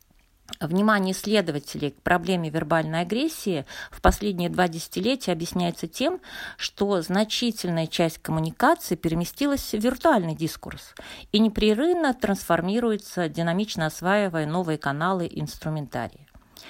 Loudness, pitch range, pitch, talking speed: -25 LUFS, 165-215 Hz, 180 Hz, 105 wpm